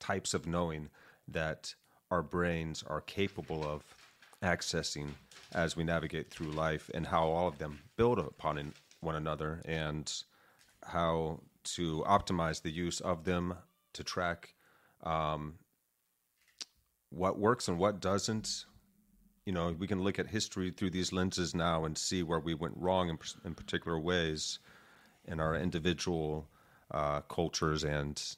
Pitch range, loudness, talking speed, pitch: 75-90 Hz, -36 LUFS, 140 wpm, 85 Hz